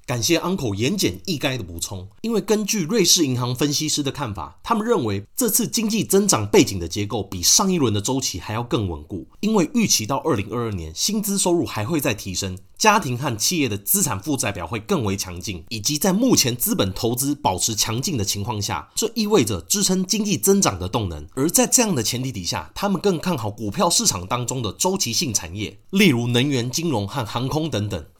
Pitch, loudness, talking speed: 125 Hz, -21 LUFS, 335 characters per minute